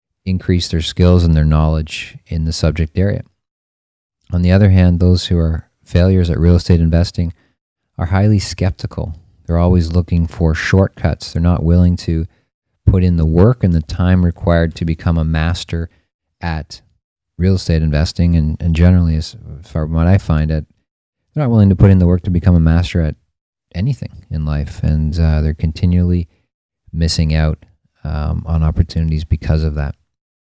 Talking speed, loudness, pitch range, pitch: 175 wpm, -15 LUFS, 80-90 Hz, 85 Hz